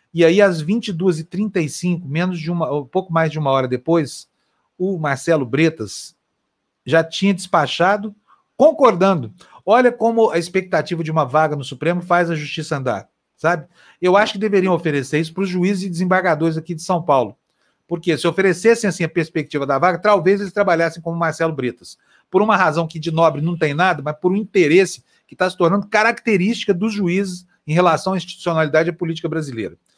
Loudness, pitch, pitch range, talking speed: -18 LUFS, 175 Hz, 160-195 Hz, 185 wpm